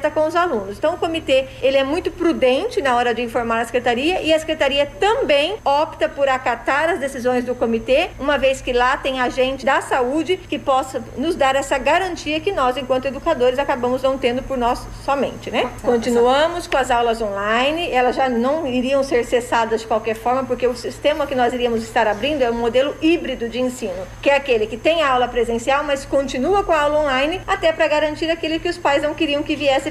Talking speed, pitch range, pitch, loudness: 210 wpm, 250-305 Hz, 270 Hz, -19 LUFS